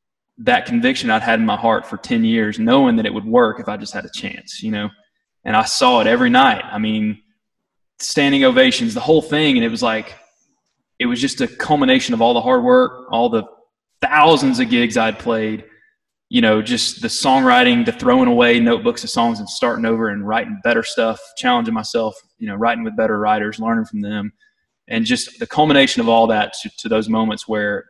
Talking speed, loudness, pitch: 210 wpm, -16 LUFS, 220 Hz